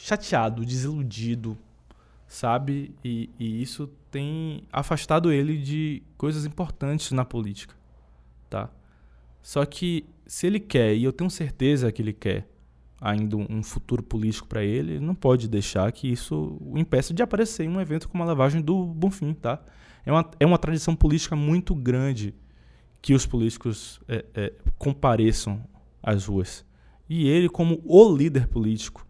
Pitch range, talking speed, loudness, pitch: 110-155 Hz, 150 wpm, -25 LUFS, 130 Hz